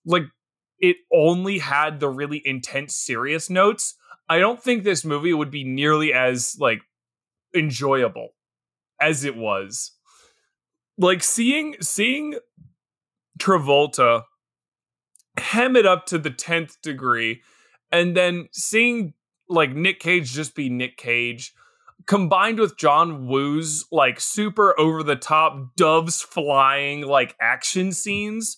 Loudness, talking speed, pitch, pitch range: -20 LUFS, 120 wpm, 160 Hz, 140-195 Hz